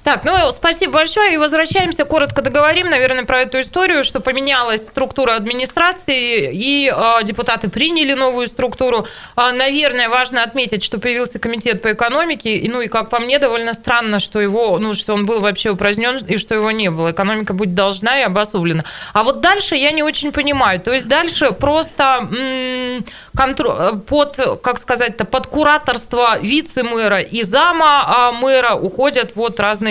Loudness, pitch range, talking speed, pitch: -15 LUFS, 225-285 Hz, 165 wpm, 250 Hz